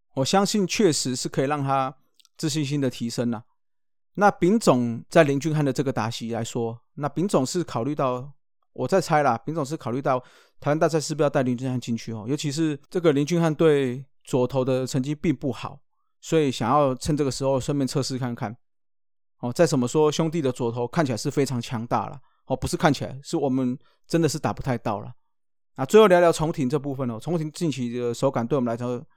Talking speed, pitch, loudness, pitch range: 320 characters per minute, 135 Hz, -24 LUFS, 125-155 Hz